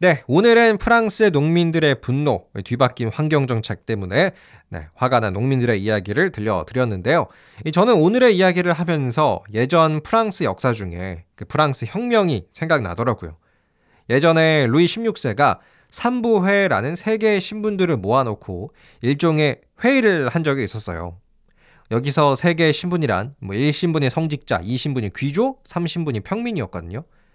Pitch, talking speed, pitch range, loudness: 145 Hz, 320 characters per minute, 110-175 Hz, -19 LUFS